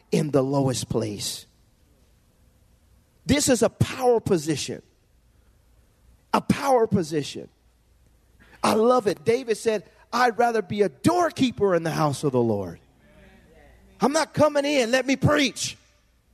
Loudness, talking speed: -23 LUFS, 130 wpm